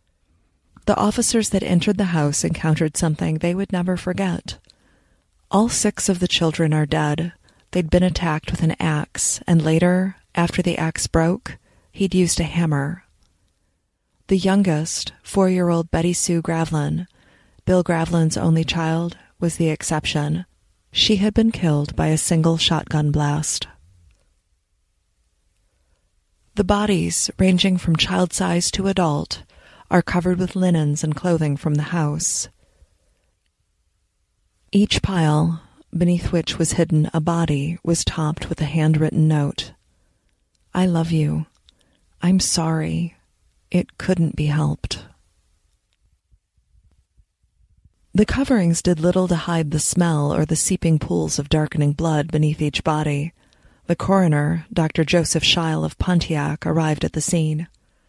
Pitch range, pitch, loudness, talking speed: 110-175 Hz, 160 Hz, -20 LUFS, 130 wpm